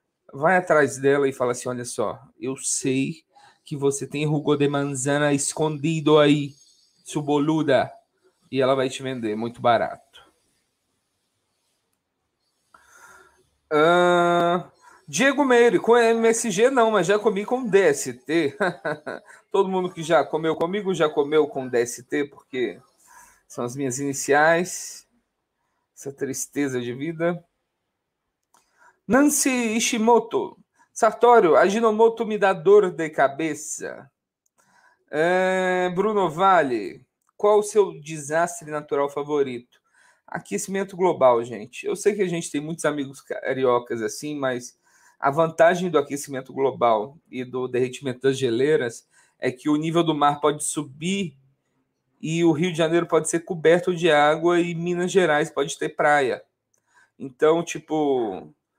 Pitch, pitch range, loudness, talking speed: 155 Hz, 140-185 Hz, -22 LUFS, 130 wpm